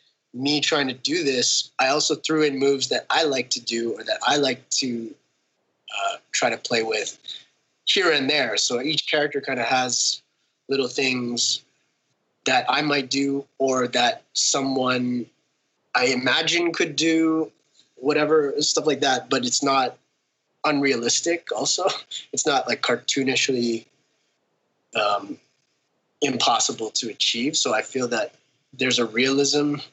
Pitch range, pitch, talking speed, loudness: 130-150 Hz, 140 Hz, 140 wpm, -22 LUFS